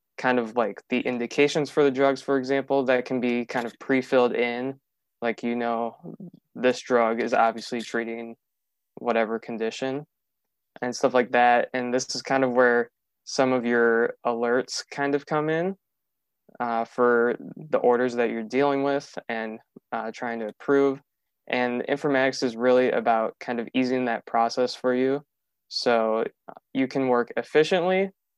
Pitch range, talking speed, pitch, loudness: 120-135 Hz, 160 wpm, 125 Hz, -25 LUFS